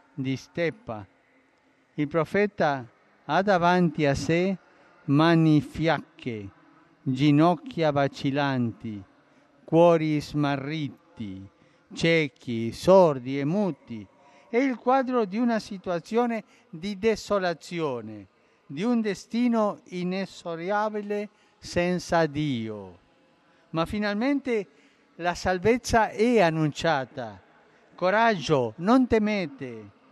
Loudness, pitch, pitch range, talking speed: -25 LUFS, 165 Hz, 140-205 Hz, 80 wpm